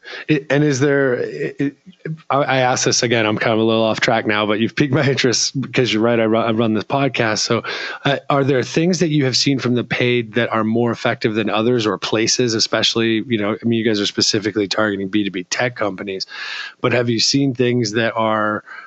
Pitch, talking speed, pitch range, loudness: 115 Hz, 230 wpm, 110-130 Hz, -17 LUFS